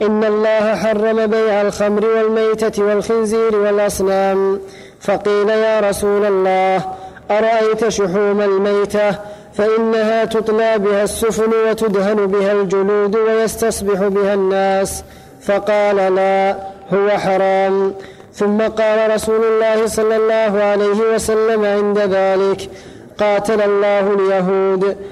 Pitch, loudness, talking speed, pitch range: 205 Hz, -15 LUFS, 100 wpm, 195-220 Hz